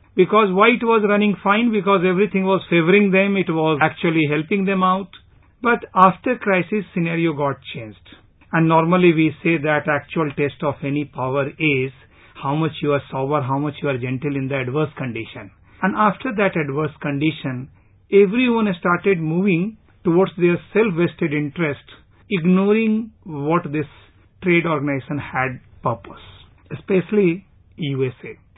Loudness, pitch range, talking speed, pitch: -19 LUFS, 140-195 Hz, 145 wpm, 165 Hz